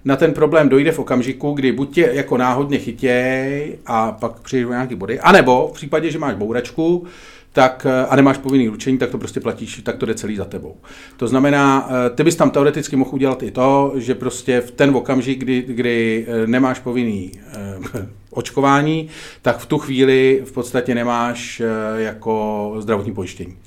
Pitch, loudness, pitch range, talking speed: 130 Hz, -17 LUFS, 120-140 Hz, 175 wpm